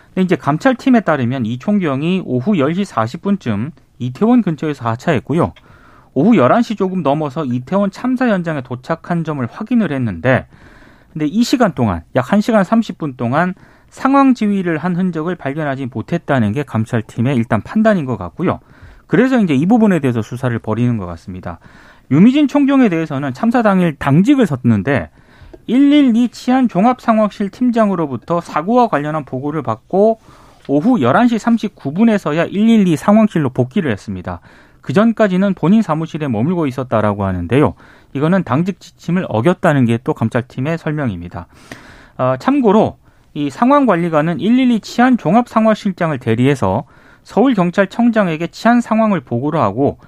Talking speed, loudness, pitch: 325 characters per minute, -15 LUFS, 165 Hz